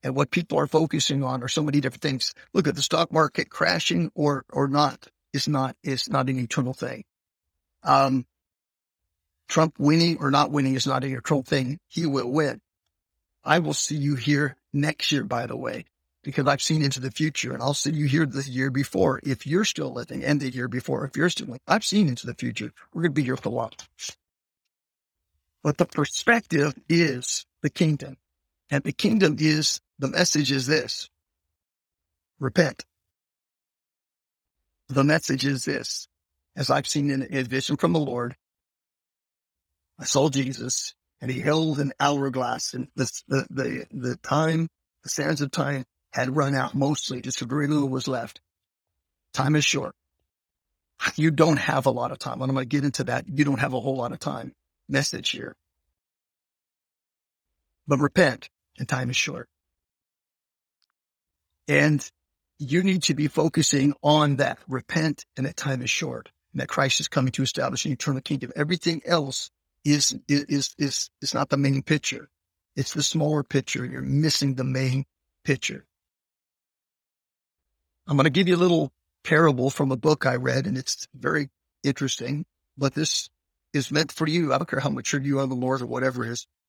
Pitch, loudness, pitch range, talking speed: 135 Hz, -25 LUFS, 125-150 Hz, 180 wpm